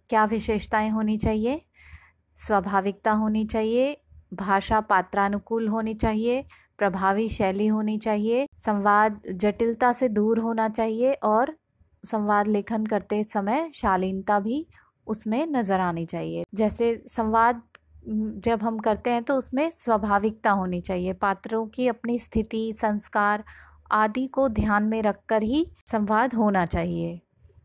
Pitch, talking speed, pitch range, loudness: 220 Hz, 125 wpm, 205-230 Hz, -25 LUFS